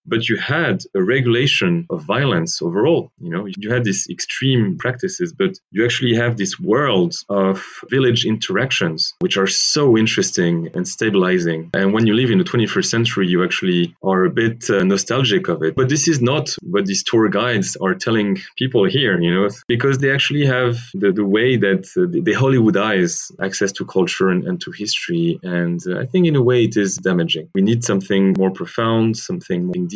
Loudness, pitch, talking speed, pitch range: -17 LUFS, 115 Hz, 200 wpm, 95-160 Hz